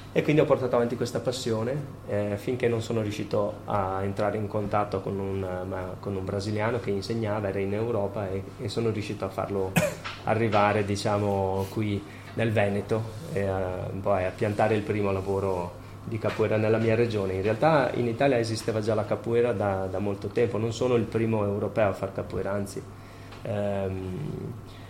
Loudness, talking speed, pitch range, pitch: -28 LUFS, 175 wpm, 95-115 Hz, 105 Hz